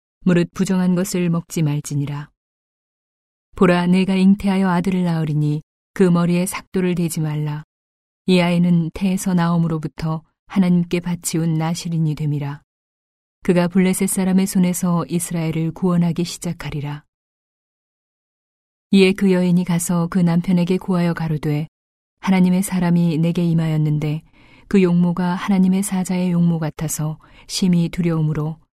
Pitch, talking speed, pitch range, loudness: 175 Hz, 305 characters per minute, 155-185 Hz, -19 LUFS